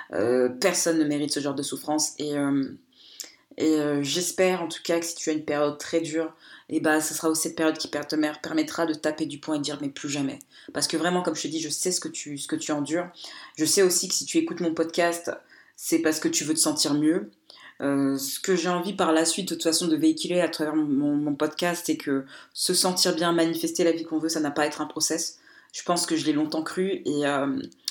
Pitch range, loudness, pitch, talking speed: 150-170 Hz, -25 LUFS, 155 Hz, 270 wpm